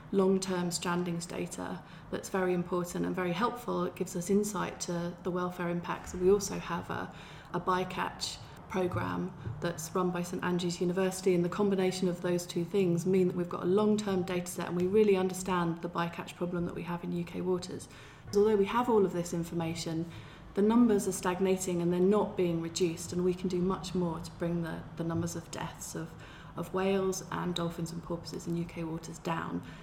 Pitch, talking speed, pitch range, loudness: 180 Hz, 200 wpm, 170-185 Hz, -32 LUFS